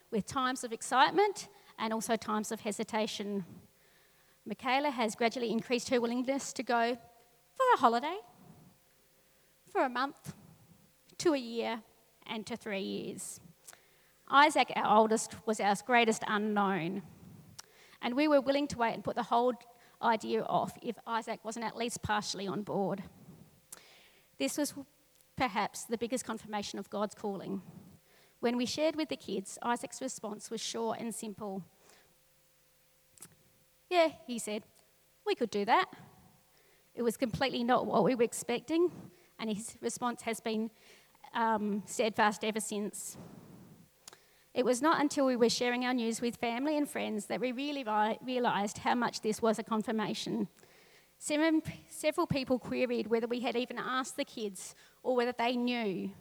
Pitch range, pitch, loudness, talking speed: 210-250 Hz, 230 Hz, -33 LUFS, 150 wpm